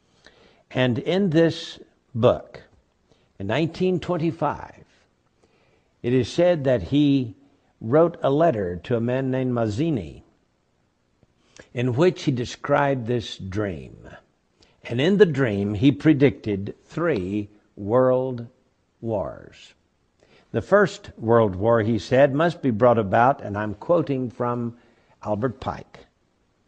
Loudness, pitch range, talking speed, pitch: -22 LUFS, 110-145 Hz, 110 wpm, 125 Hz